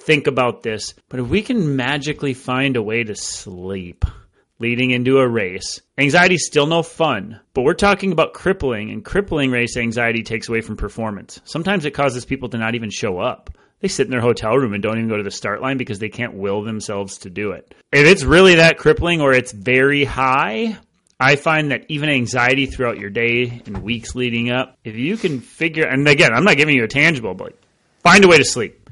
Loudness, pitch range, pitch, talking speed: -17 LUFS, 110-150 Hz, 125 Hz, 220 wpm